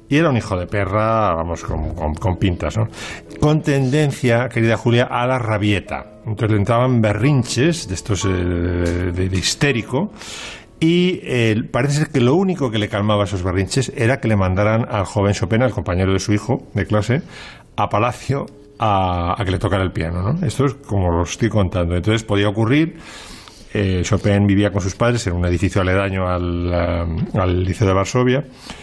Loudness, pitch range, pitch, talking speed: -18 LUFS, 95-125 Hz, 105 Hz, 185 wpm